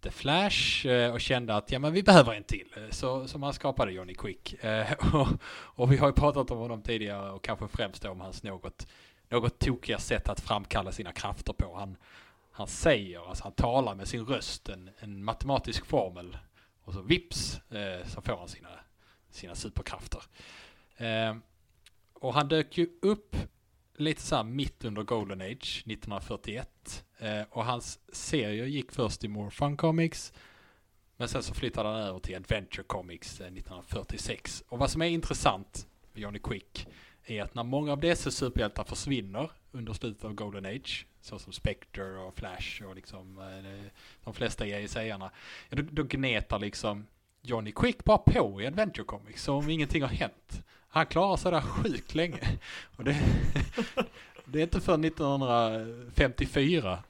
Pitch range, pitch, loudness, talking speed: 100-135 Hz, 110 Hz, -31 LUFS, 160 wpm